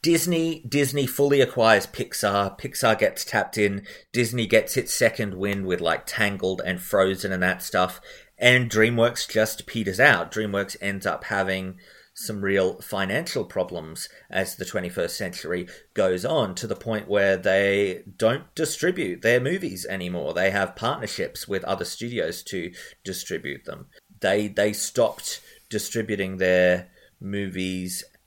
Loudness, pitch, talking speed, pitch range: -24 LUFS, 100 Hz, 140 wpm, 95-115 Hz